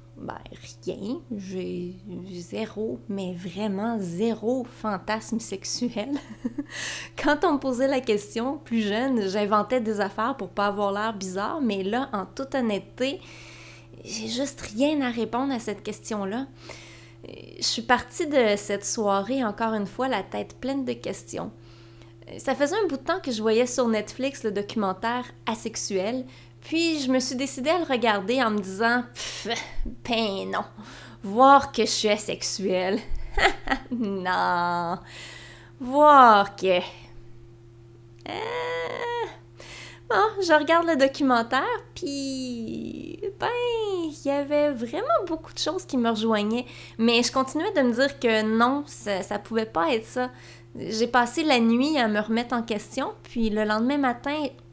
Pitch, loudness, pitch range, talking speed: 230 Hz, -25 LUFS, 200-270 Hz, 145 wpm